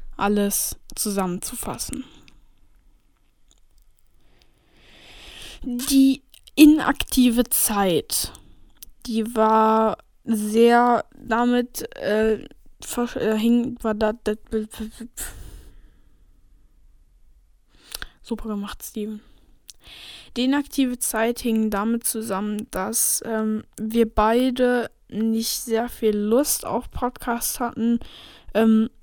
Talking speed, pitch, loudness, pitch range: 80 wpm, 225 Hz, -22 LUFS, 215-245 Hz